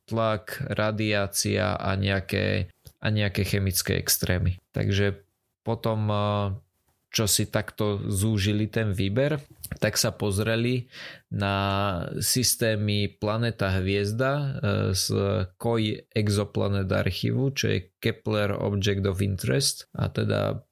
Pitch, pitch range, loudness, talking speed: 105 Hz, 100-115 Hz, -26 LUFS, 100 wpm